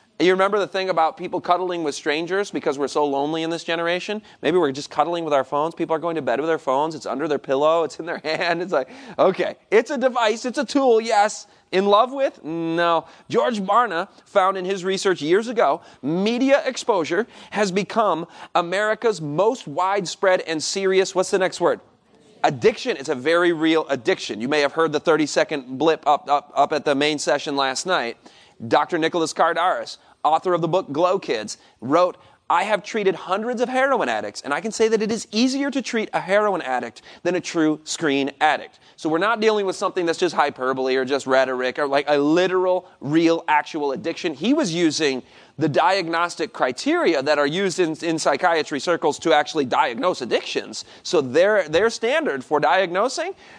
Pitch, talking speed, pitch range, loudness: 170 Hz, 195 wpm, 150-200 Hz, -21 LUFS